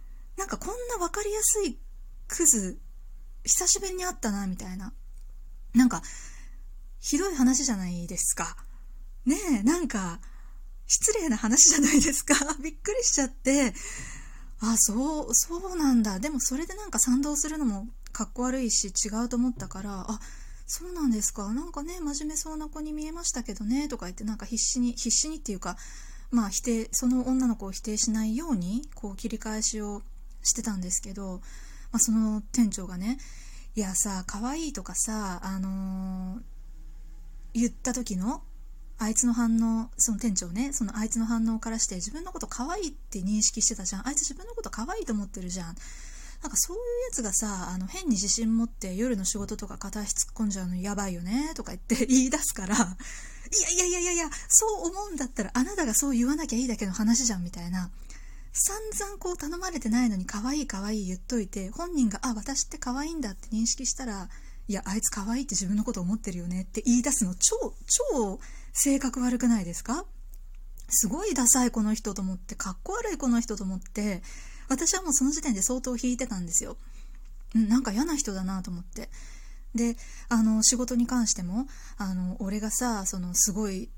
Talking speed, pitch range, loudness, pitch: 365 characters per minute, 205-280 Hz, -27 LUFS, 230 Hz